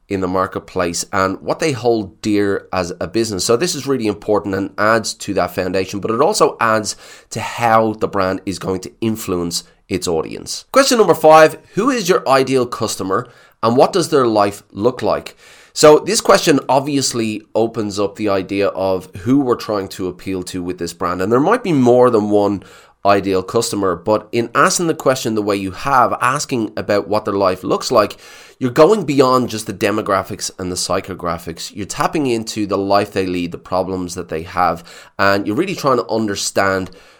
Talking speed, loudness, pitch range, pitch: 195 wpm, -16 LUFS, 95-120 Hz, 105 Hz